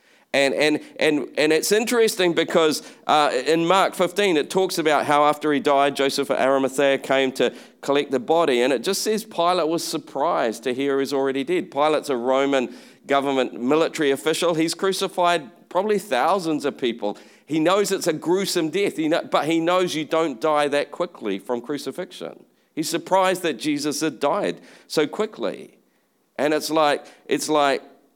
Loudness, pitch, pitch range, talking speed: -21 LUFS, 155 Hz, 140-180 Hz, 170 wpm